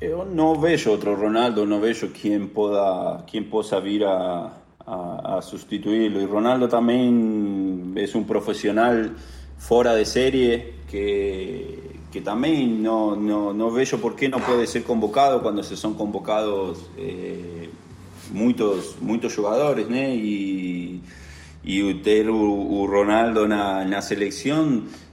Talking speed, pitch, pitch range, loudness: 130 wpm, 105 Hz, 100-115 Hz, -22 LUFS